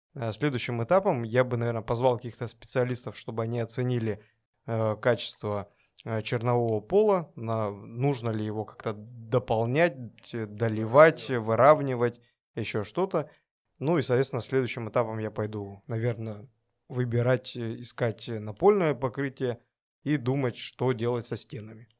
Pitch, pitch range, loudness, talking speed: 120 Hz, 115-130 Hz, -28 LUFS, 115 wpm